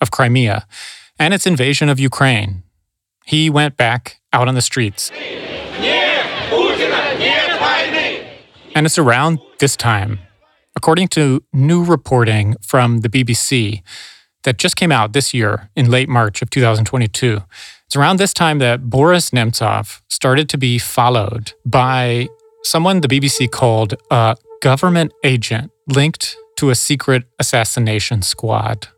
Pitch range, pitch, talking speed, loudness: 115-150 Hz, 125 Hz, 130 wpm, -15 LUFS